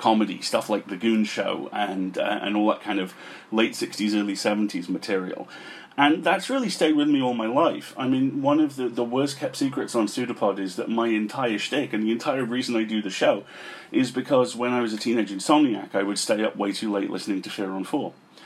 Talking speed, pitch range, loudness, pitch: 230 wpm, 105-135 Hz, -25 LUFS, 115 Hz